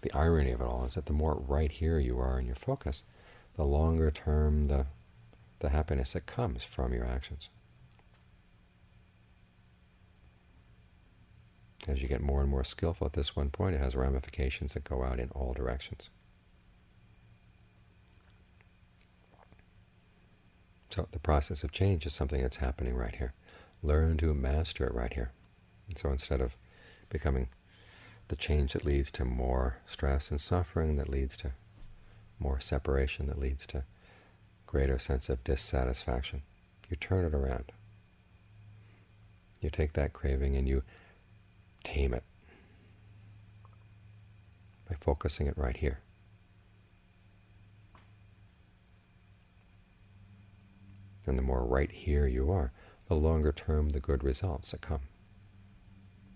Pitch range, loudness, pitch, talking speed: 70-100 Hz, -34 LUFS, 85 Hz, 130 wpm